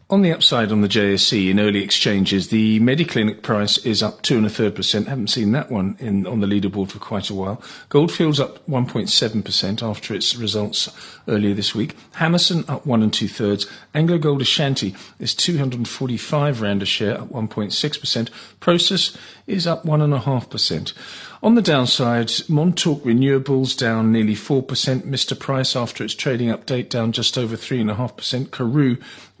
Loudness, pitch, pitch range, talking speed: -19 LUFS, 120 Hz, 105-145 Hz, 185 wpm